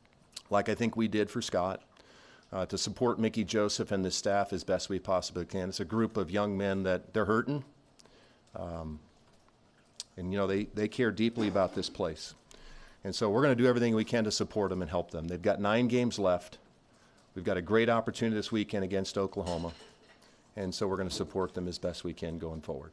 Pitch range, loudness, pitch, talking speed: 90-110 Hz, -32 LUFS, 100 Hz, 215 wpm